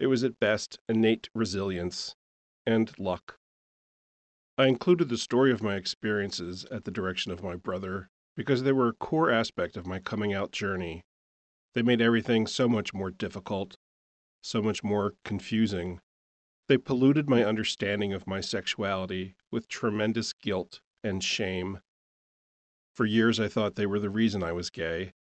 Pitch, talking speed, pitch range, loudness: 100 Hz, 155 wpm, 90-115 Hz, -29 LUFS